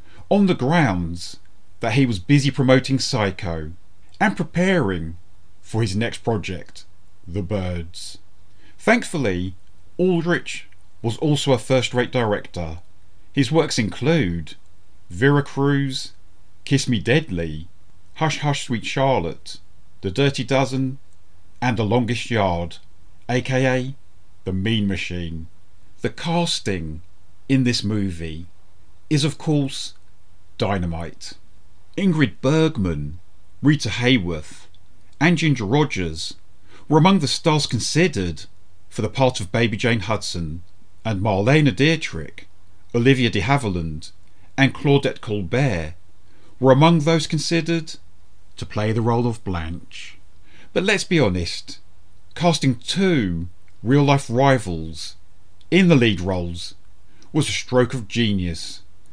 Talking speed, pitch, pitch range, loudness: 115 wpm, 100 Hz, 90-135 Hz, -21 LUFS